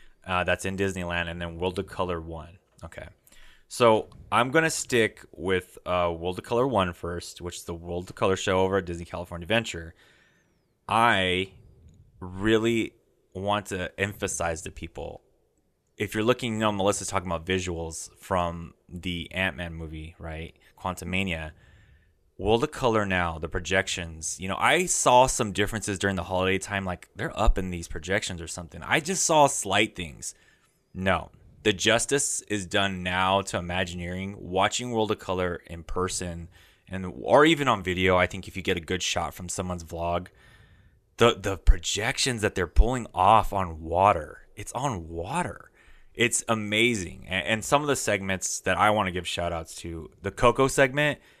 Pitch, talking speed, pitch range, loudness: 95 Hz, 175 wpm, 85-105 Hz, -26 LUFS